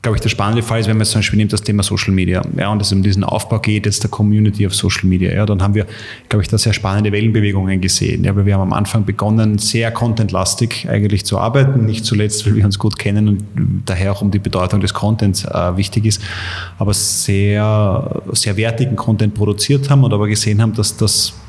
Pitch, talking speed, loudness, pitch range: 105 Hz, 235 wpm, -15 LUFS, 100-110 Hz